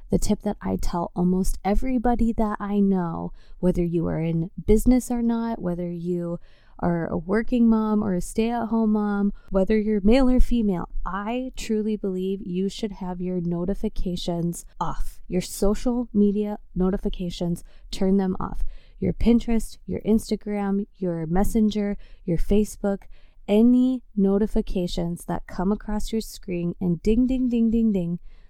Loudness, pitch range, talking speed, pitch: -24 LUFS, 180-220 Hz, 150 wpm, 205 Hz